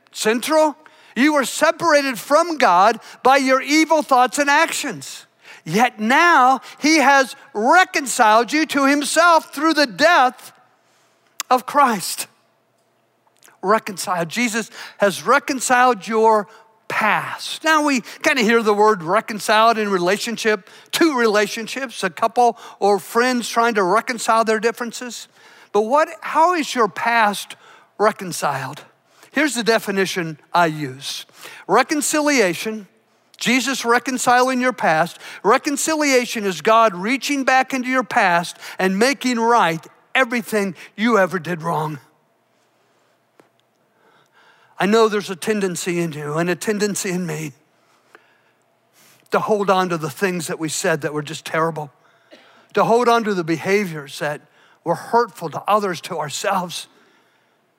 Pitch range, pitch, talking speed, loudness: 185-260 Hz, 225 Hz, 130 wpm, -18 LUFS